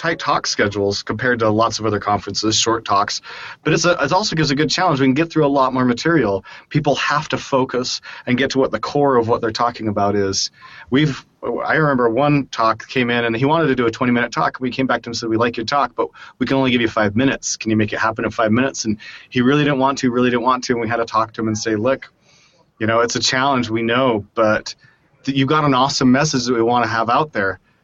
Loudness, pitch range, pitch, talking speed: -18 LUFS, 115-140 Hz, 125 Hz, 275 wpm